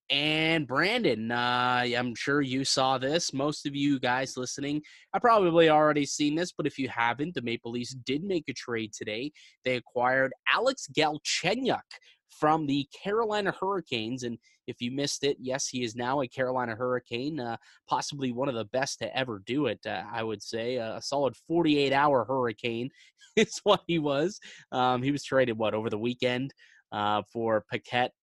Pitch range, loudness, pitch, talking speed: 120-150 Hz, -28 LUFS, 130 Hz, 180 wpm